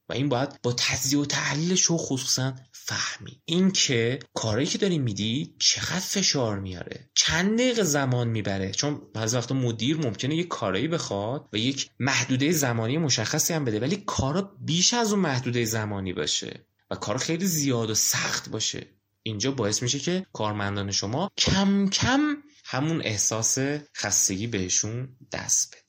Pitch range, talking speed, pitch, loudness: 110-160 Hz, 155 wpm, 135 Hz, -25 LUFS